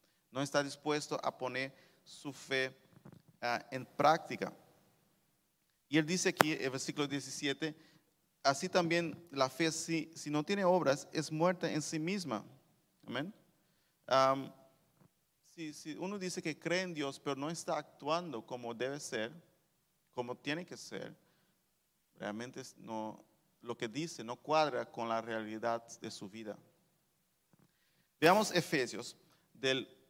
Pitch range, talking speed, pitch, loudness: 130-165 Hz, 135 wpm, 150 Hz, -36 LUFS